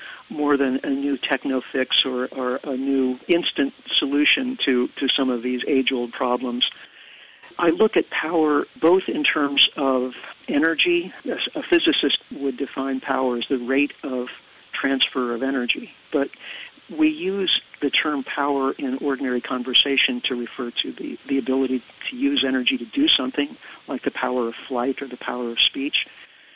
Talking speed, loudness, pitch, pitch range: 165 wpm, -22 LUFS, 135 Hz, 125-150 Hz